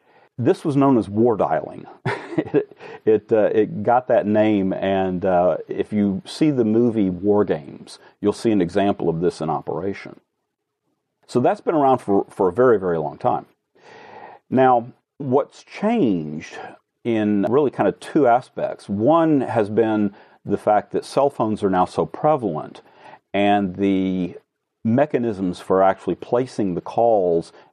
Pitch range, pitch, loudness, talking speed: 95-125 Hz, 105 Hz, -20 LUFS, 155 wpm